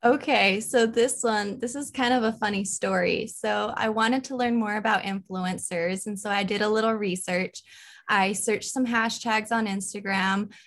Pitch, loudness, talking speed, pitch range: 215 Hz, -25 LUFS, 180 wpm, 195-235 Hz